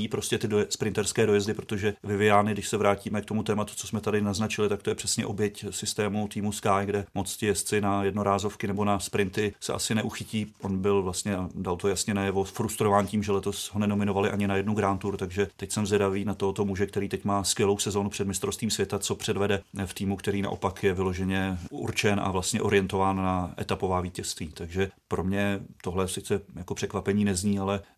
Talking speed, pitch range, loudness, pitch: 200 wpm, 100-105 Hz, -28 LUFS, 100 Hz